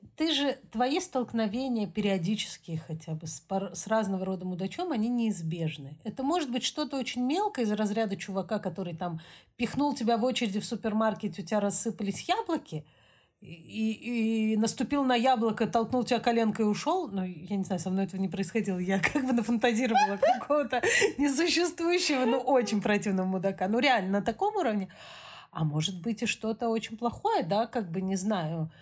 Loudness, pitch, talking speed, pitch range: -29 LUFS, 220 Hz, 175 wpm, 195-255 Hz